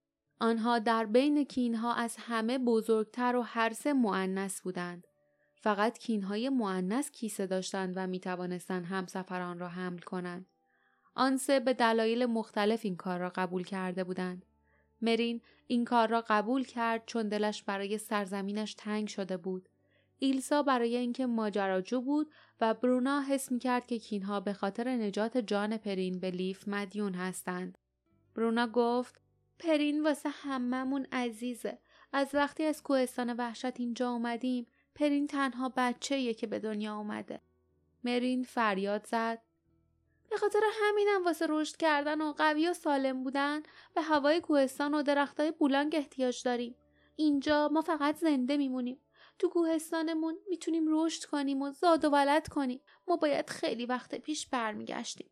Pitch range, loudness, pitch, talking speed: 210-285 Hz, -32 LUFS, 245 Hz, 145 wpm